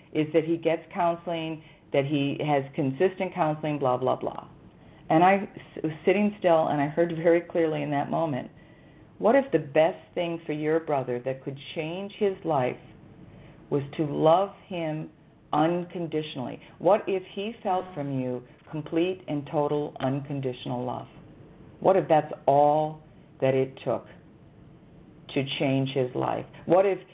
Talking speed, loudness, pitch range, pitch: 150 wpm, -27 LUFS, 145-170 Hz, 155 Hz